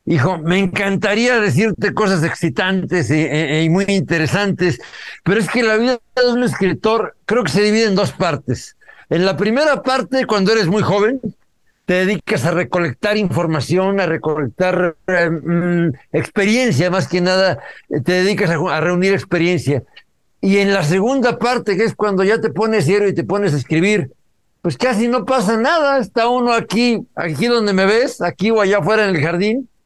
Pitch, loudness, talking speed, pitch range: 195 Hz, -16 LUFS, 175 wpm, 175-220 Hz